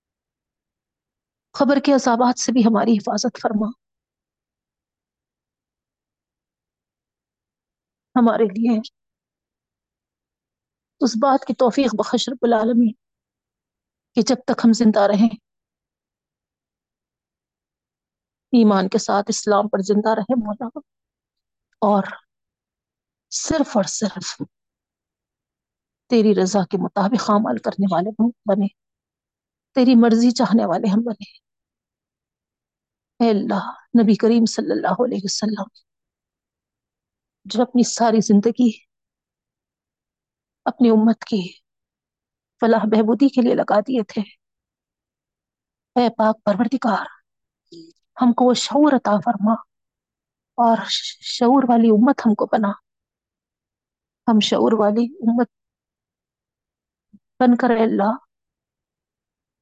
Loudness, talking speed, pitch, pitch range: -18 LUFS, 95 wpm, 230 Hz, 210-245 Hz